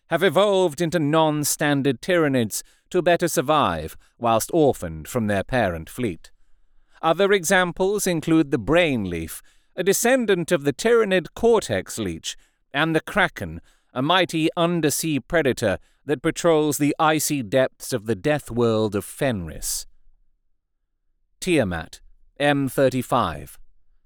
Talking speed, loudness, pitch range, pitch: 120 wpm, -22 LUFS, 110-170 Hz, 150 Hz